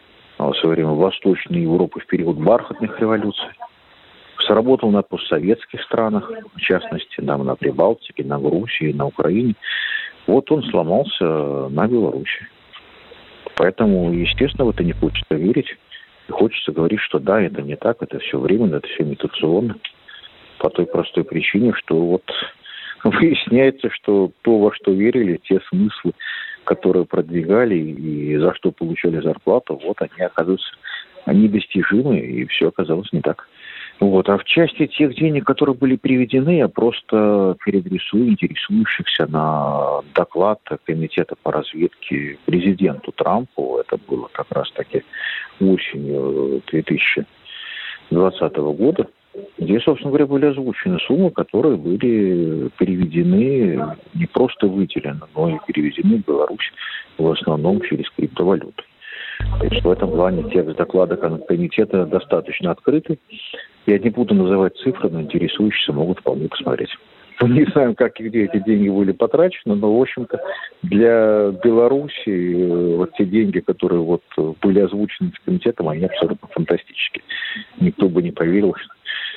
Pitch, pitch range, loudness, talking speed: 105 Hz, 90-150 Hz, -18 LUFS, 135 wpm